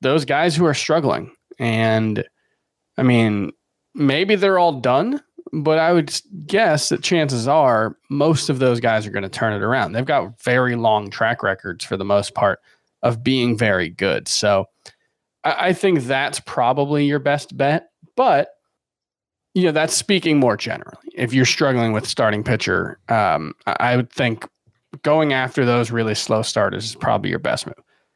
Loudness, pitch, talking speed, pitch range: -19 LUFS, 130 Hz, 175 wpm, 115-155 Hz